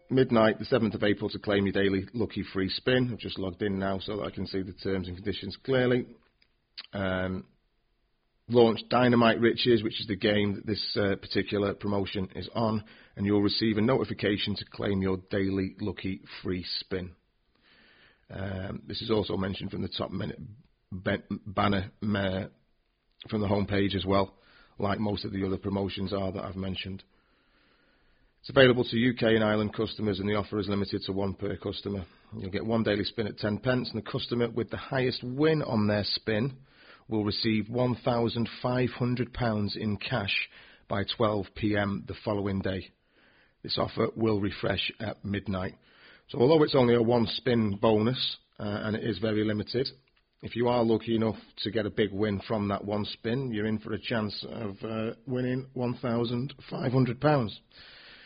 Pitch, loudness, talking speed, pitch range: 105 Hz, -29 LUFS, 175 wpm, 100-115 Hz